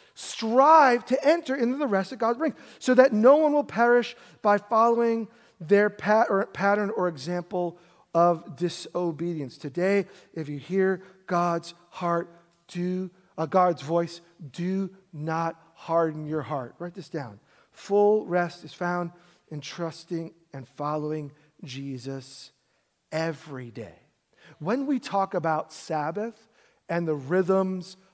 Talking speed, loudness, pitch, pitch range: 135 wpm, -26 LUFS, 175 Hz, 160-205 Hz